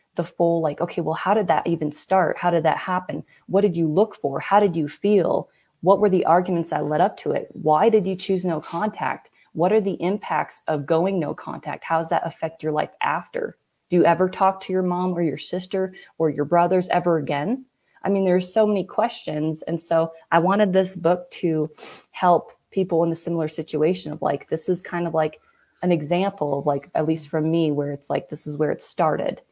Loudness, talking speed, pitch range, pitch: -22 LUFS, 225 wpm, 160-190 Hz, 170 Hz